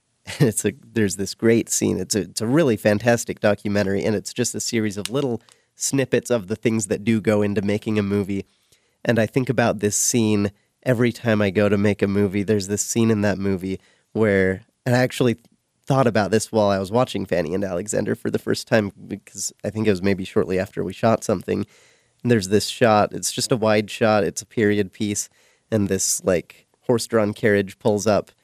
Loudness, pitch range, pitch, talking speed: -21 LUFS, 100-115 Hz, 105 Hz, 215 wpm